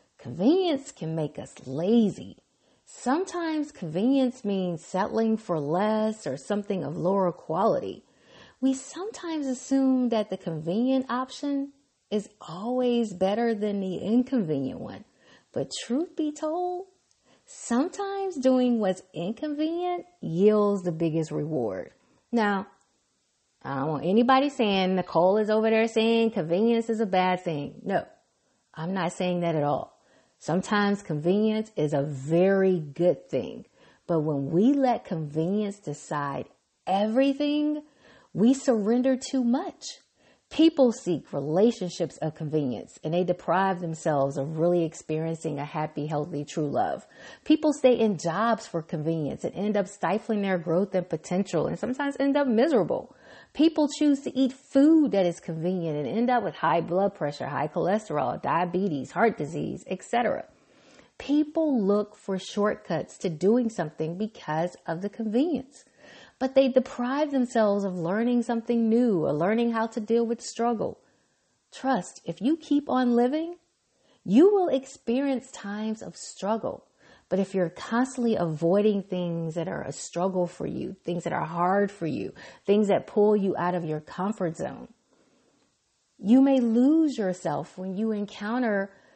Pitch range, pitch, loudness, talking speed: 175-255 Hz, 210 Hz, -26 LUFS, 145 wpm